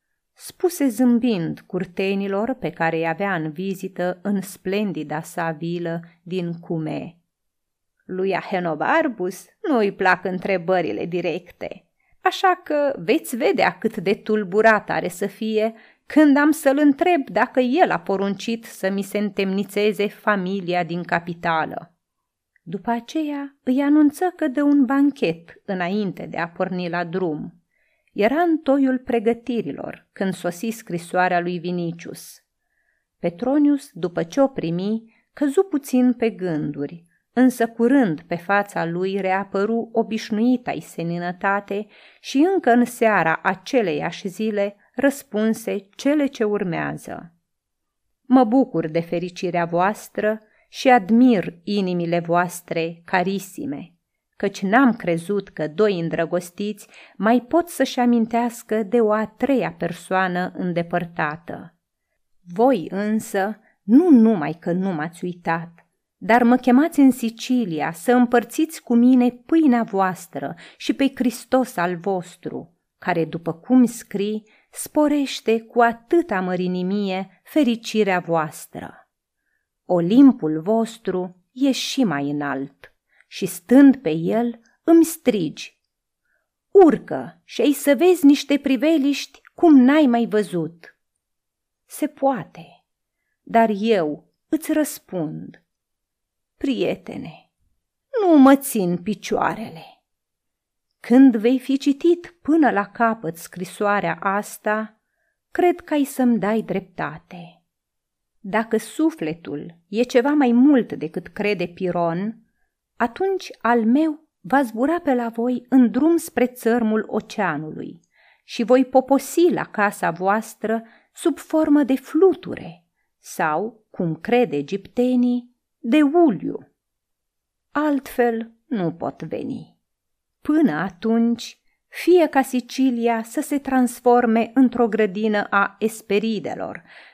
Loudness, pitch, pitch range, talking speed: -20 LUFS, 220 Hz, 185-260 Hz, 115 wpm